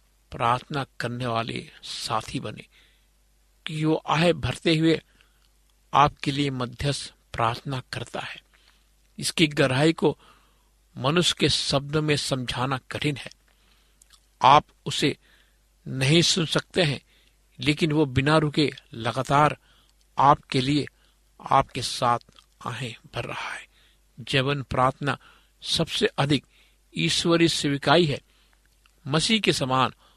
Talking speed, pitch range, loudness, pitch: 110 wpm, 125-155 Hz, -24 LUFS, 140 Hz